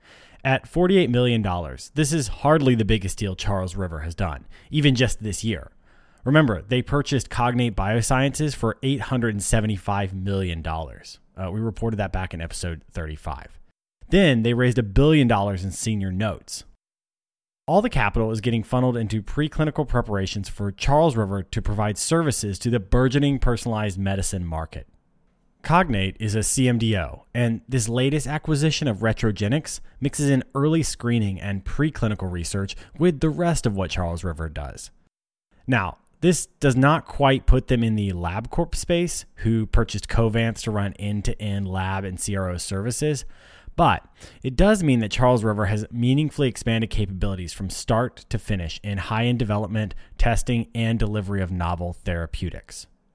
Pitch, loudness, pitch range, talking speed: 110 Hz, -23 LUFS, 95-130 Hz, 155 wpm